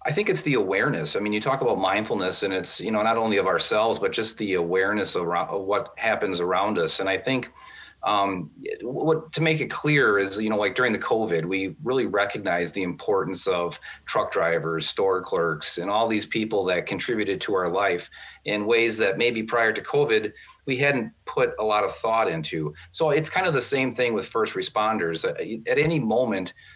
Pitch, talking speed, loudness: 125 Hz, 205 wpm, -24 LUFS